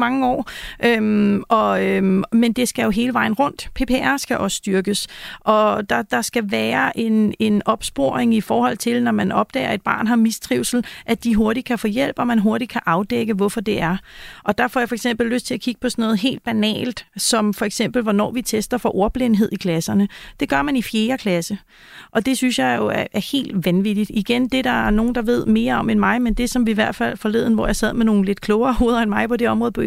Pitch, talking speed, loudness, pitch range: 225 Hz, 245 wpm, -19 LUFS, 210-245 Hz